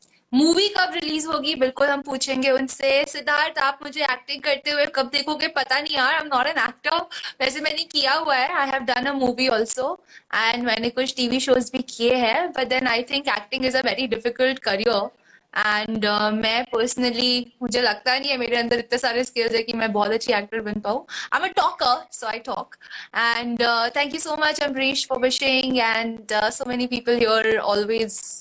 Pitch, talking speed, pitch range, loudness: 255 Hz, 195 wpm, 230-275 Hz, -21 LUFS